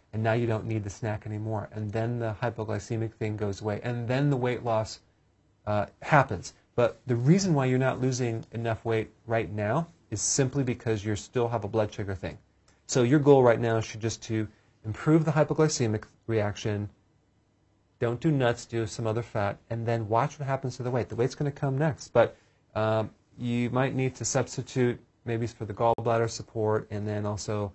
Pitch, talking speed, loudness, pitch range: 115 Hz, 195 wpm, -28 LUFS, 110-125 Hz